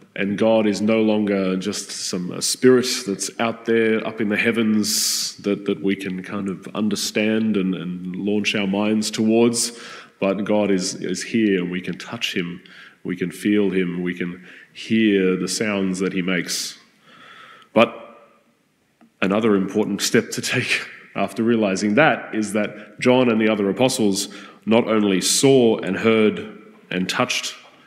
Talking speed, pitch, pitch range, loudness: 160 wpm, 105 Hz, 95-110 Hz, -20 LUFS